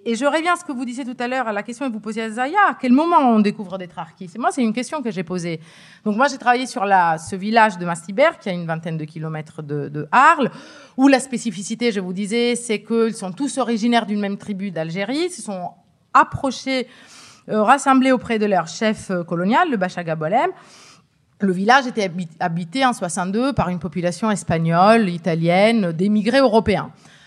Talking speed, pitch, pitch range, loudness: 205 wpm, 215 Hz, 180-250 Hz, -19 LUFS